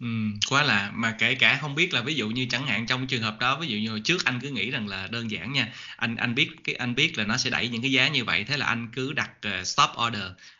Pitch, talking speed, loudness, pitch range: 120 Hz, 300 wpm, -25 LUFS, 110-135 Hz